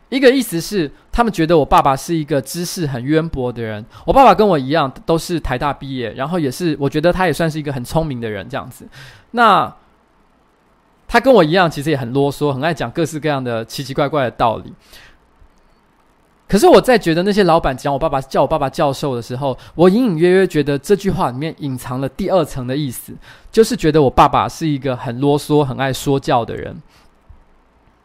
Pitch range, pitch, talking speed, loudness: 135-175 Hz, 150 Hz, 310 characters per minute, -16 LUFS